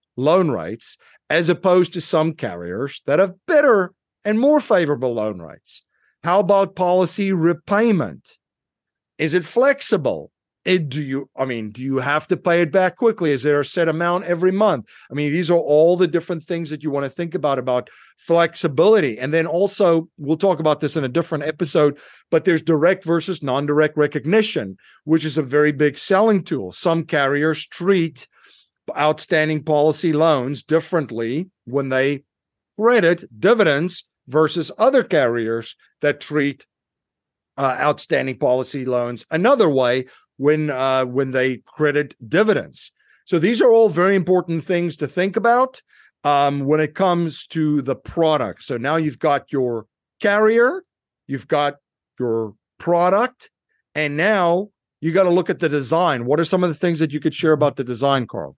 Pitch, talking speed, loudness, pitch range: 155 Hz, 165 wpm, -19 LUFS, 140-180 Hz